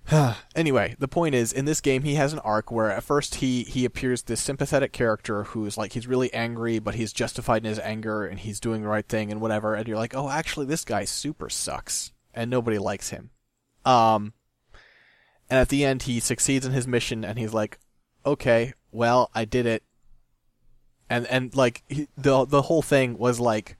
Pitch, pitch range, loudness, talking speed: 120 Hz, 110-135 Hz, -25 LUFS, 200 wpm